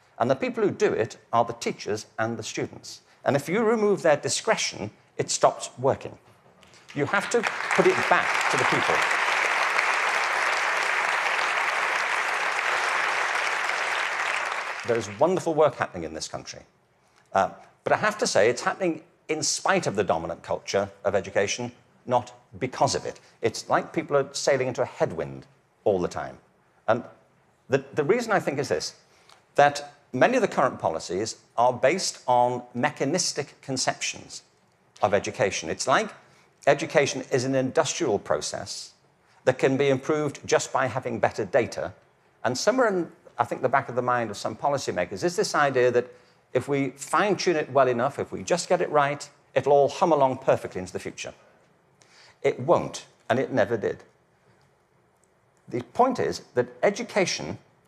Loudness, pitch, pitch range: -25 LUFS, 140 Hz, 125-160 Hz